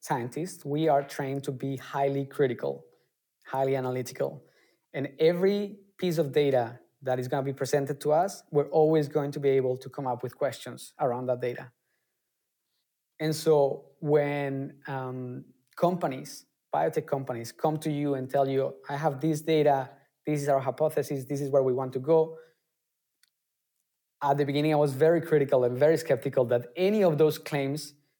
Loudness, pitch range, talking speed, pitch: -28 LUFS, 135-155 Hz, 170 wpm, 140 Hz